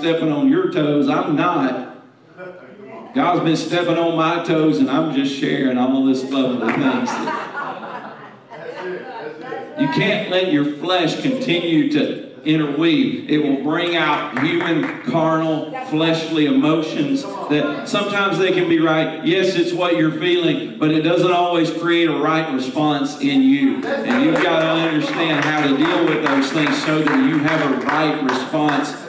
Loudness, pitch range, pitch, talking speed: -18 LUFS, 150-190 Hz, 165 Hz, 160 wpm